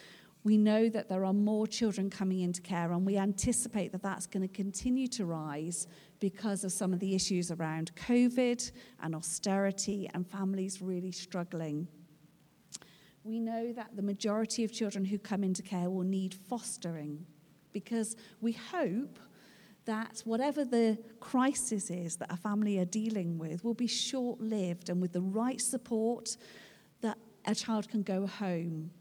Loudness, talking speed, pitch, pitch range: -34 LUFS, 160 wpm, 200 Hz, 180-225 Hz